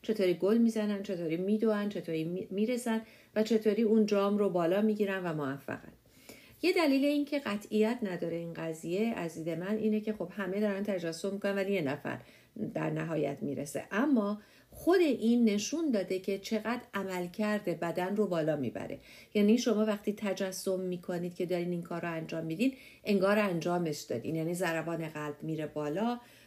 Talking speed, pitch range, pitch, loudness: 165 wpm, 170-215 Hz, 195 Hz, -32 LUFS